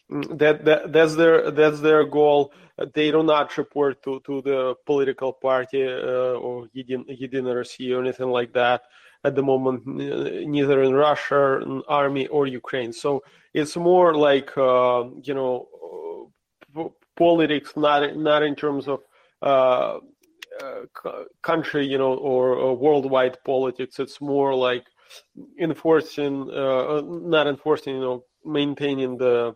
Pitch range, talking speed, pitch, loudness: 130-150 Hz, 135 wpm, 140 Hz, -22 LUFS